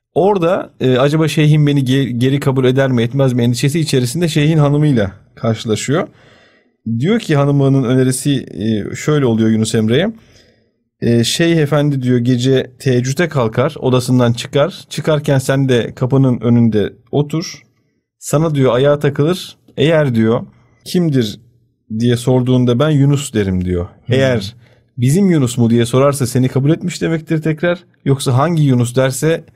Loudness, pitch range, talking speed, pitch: -14 LUFS, 120-145 Hz, 140 wpm, 130 Hz